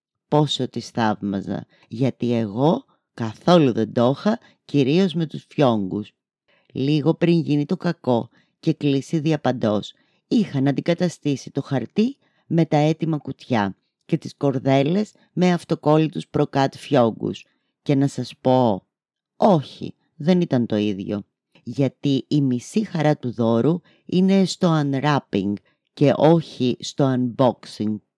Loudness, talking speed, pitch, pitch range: -21 LUFS, 125 wpm, 140 Hz, 120-165 Hz